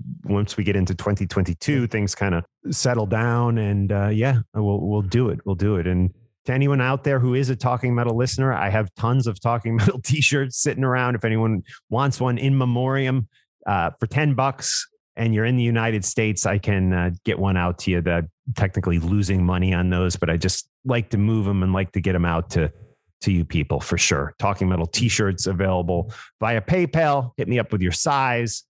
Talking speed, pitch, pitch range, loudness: 210 wpm, 110 Hz, 95-125 Hz, -22 LUFS